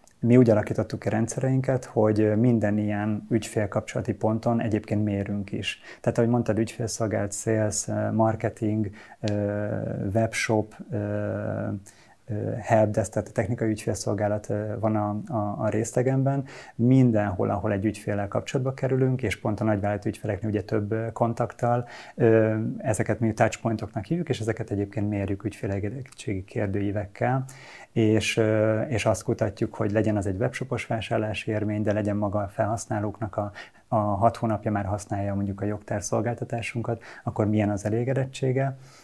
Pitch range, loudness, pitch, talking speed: 105-115 Hz, -26 LUFS, 110 Hz, 125 wpm